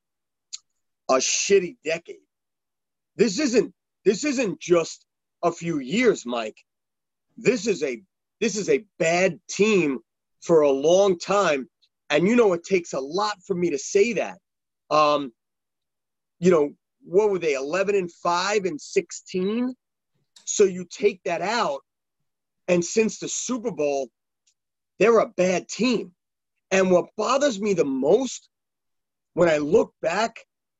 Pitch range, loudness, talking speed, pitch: 170-240 Hz, -23 LUFS, 140 wpm, 195 Hz